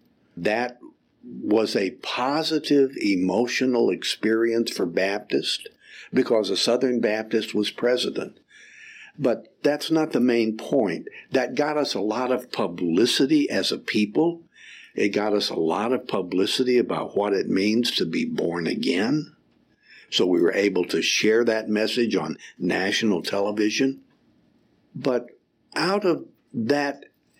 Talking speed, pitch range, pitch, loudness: 130 wpm, 105-140 Hz, 120 Hz, -23 LUFS